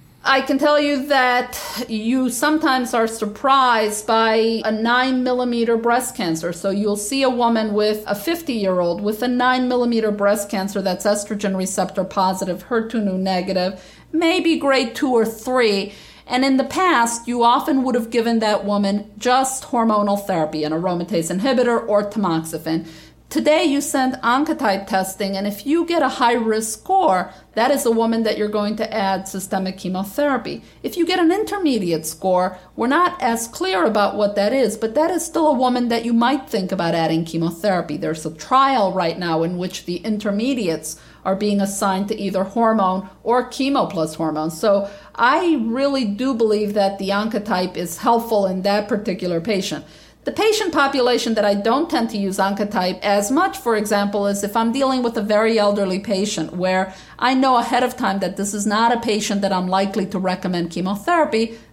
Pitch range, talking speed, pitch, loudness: 190-250 Hz, 180 wpm, 215 Hz, -19 LUFS